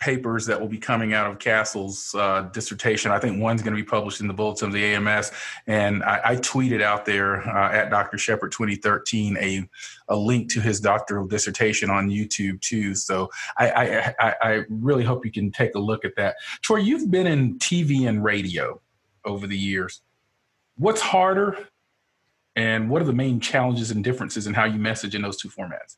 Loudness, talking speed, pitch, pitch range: -23 LUFS, 195 wpm, 110 Hz, 100-120 Hz